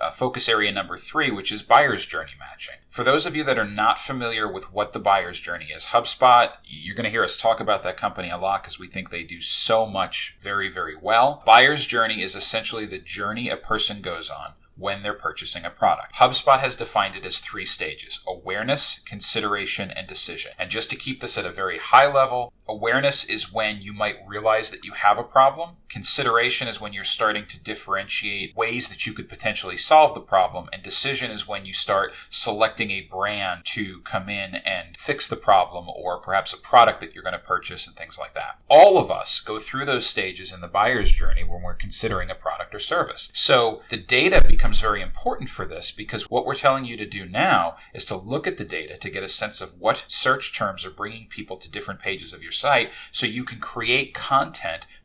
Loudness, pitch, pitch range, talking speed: -21 LUFS, 105 Hz, 95-115 Hz, 215 wpm